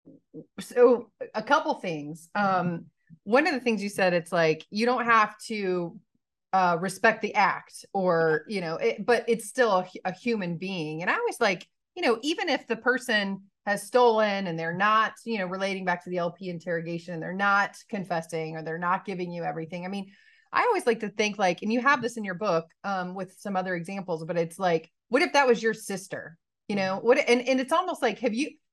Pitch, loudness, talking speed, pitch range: 200 Hz, -26 LUFS, 215 wpm, 180-235 Hz